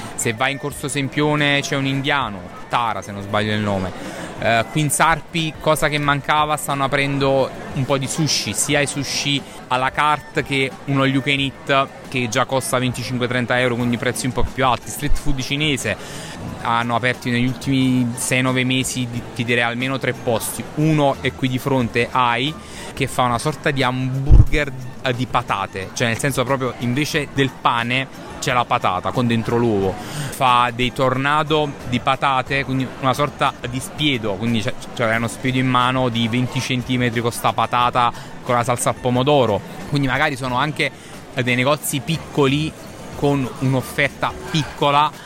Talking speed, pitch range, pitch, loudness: 170 wpm, 120-140 Hz, 130 Hz, -19 LUFS